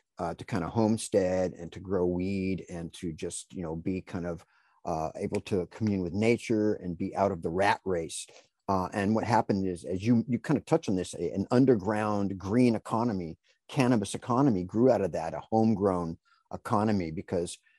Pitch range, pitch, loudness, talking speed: 90-110 Hz, 100 Hz, -29 LUFS, 190 wpm